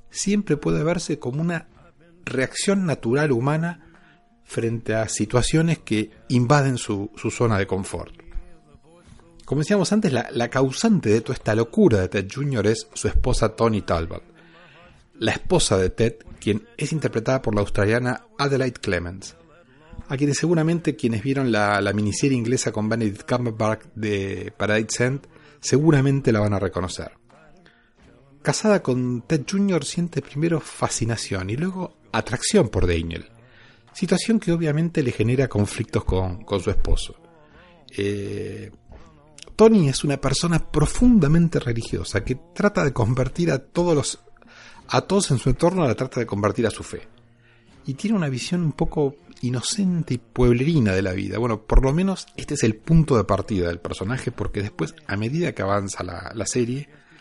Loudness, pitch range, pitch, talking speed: -22 LUFS, 105-155 Hz, 125 Hz, 155 wpm